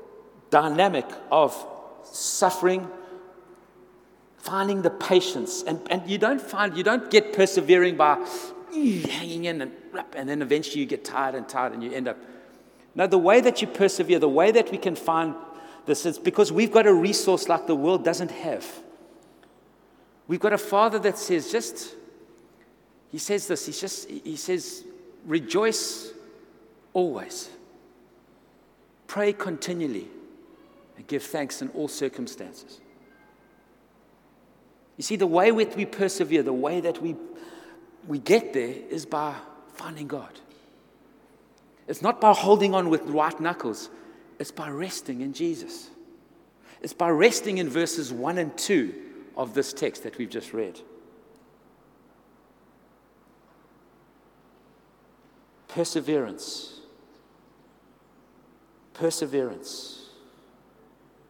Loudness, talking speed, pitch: -25 LUFS, 125 wpm, 205 Hz